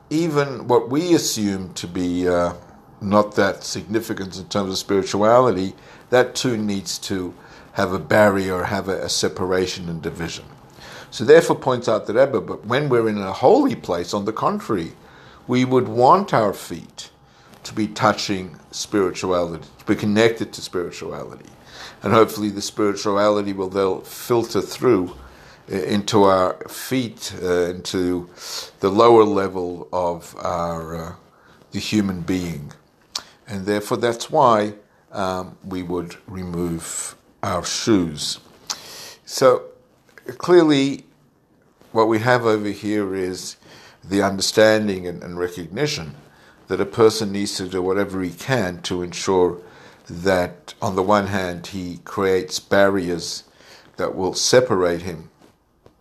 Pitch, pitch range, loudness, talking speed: 95 Hz, 90-105 Hz, -20 LUFS, 135 wpm